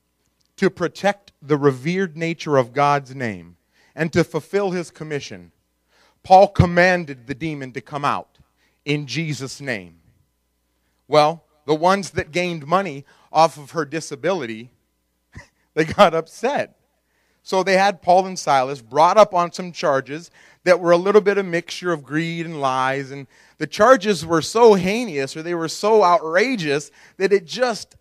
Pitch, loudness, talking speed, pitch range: 160 Hz, -19 LUFS, 155 wpm, 140-180 Hz